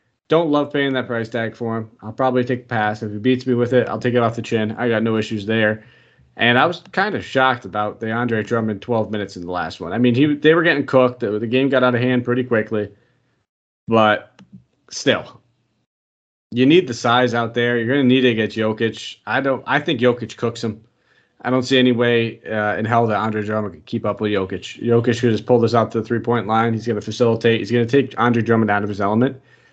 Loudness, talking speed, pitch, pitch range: -19 LUFS, 250 wpm, 115 Hz, 110-125 Hz